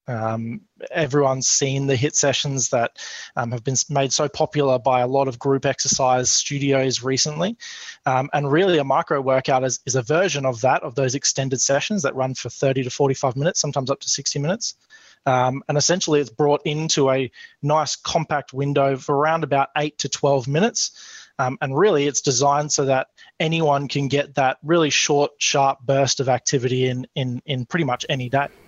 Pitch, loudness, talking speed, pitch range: 140 Hz, -20 LUFS, 190 wpm, 130-150 Hz